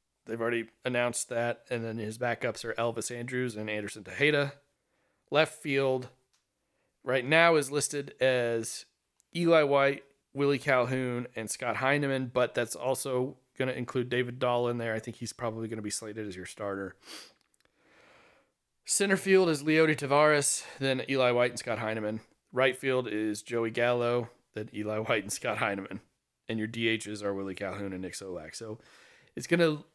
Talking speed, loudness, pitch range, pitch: 170 wpm, -30 LUFS, 110-135 Hz, 120 Hz